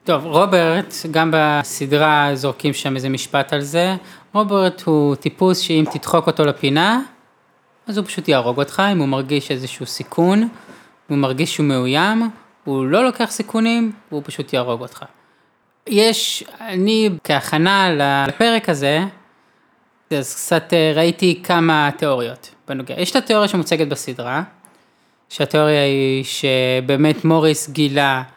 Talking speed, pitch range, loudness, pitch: 125 wpm, 140-185 Hz, -17 LUFS, 155 Hz